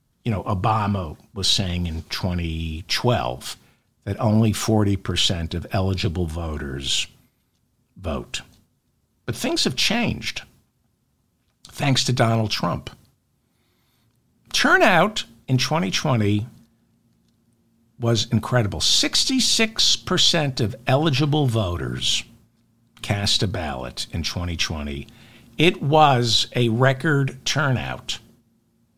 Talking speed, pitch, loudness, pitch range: 85 wpm, 115 Hz, -21 LUFS, 95-125 Hz